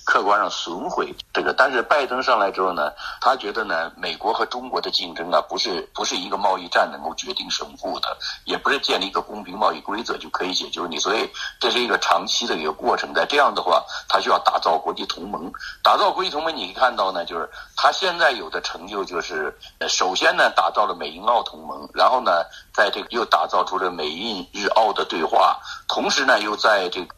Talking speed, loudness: 325 characters per minute, -21 LUFS